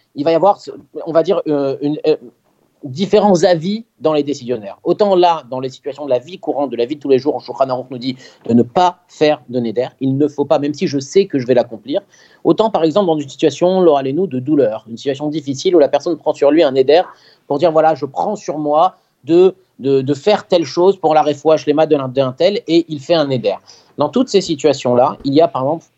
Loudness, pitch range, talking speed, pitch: -15 LUFS, 135-175 Hz, 245 wpm, 150 Hz